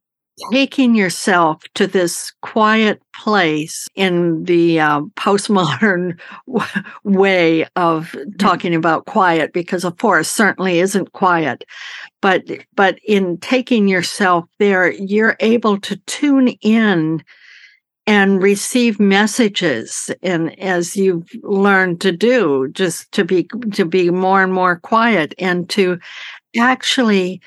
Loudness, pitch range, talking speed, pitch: -15 LUFS, 175-210 Hz, 120 wpm, 190 Hz